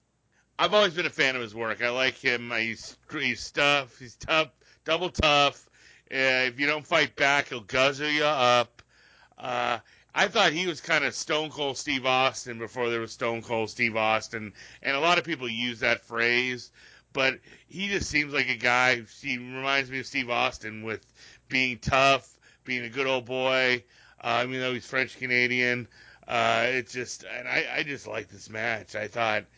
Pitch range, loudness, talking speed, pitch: 115-140 Hz, -26 LUFS, 190 wpm, 125 Hz